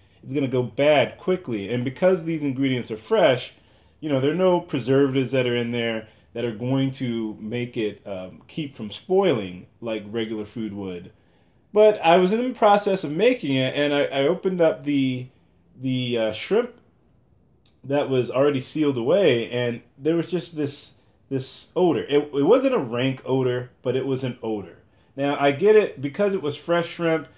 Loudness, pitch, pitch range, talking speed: -23 LUFS, 130 Hz, 115-150 Hz, 185 wpm